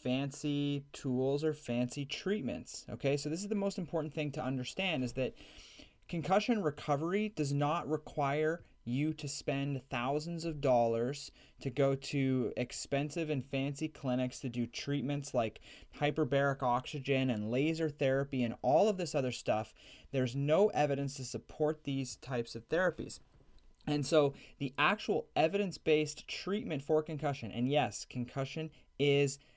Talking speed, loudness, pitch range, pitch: 145 wpm, -35 LUFS, 130-155 Hz, 140 Hz